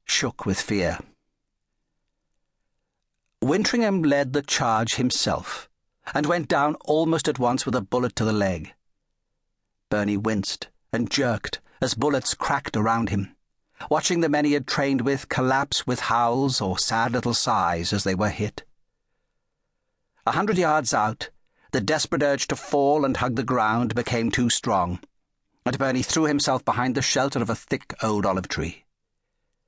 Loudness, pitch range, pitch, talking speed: -23 LUFS, 115-145 Hz, 130 Hz, 155 wpm